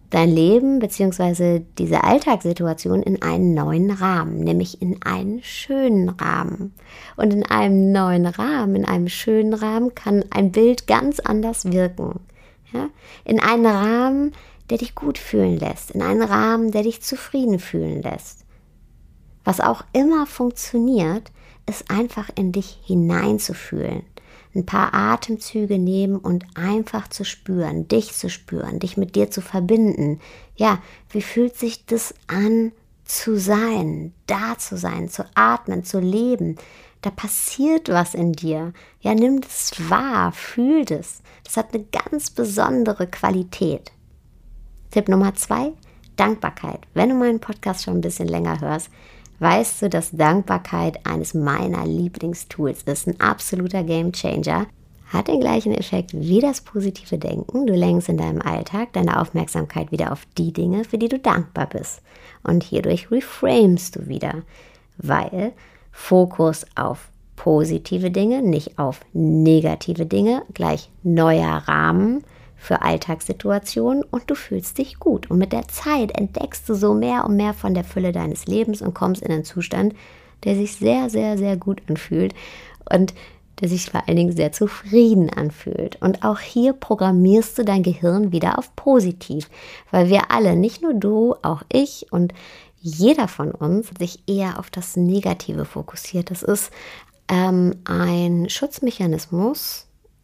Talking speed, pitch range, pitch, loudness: 145 wpm, 175-225 Hz, 195 Hz, -20 LUFS